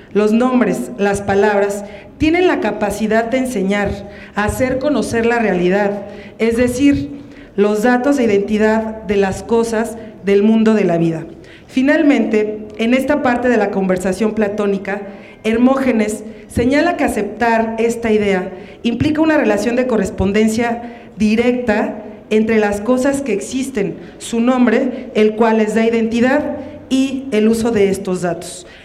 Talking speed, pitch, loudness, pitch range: 135 wpm, 220 Hz, -16 LUFS, 205-245 Hz